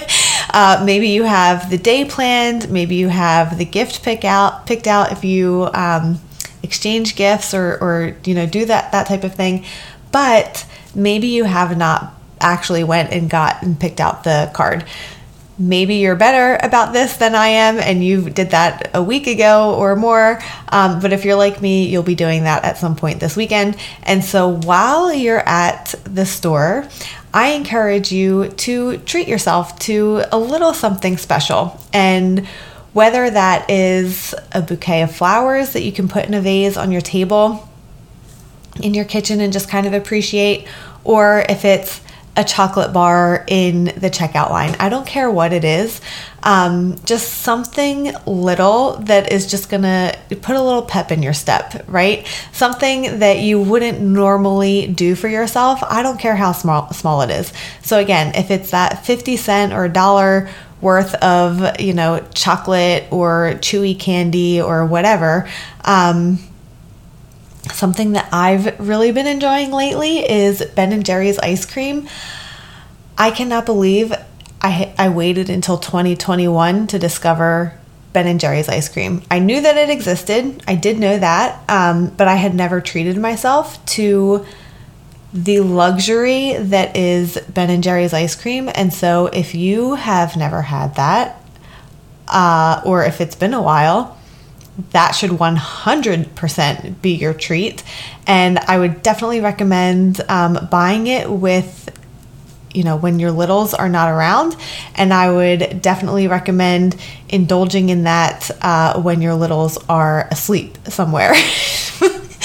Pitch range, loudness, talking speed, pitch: 175-210 Hz, -15 LUFS, 160 wpm, 185 Hz